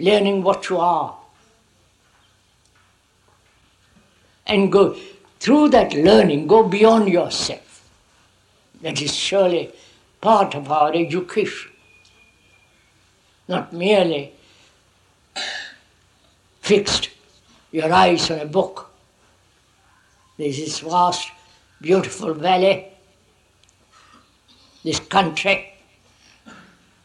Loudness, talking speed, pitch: -18 LUFS, 75 wpm, 160 Hz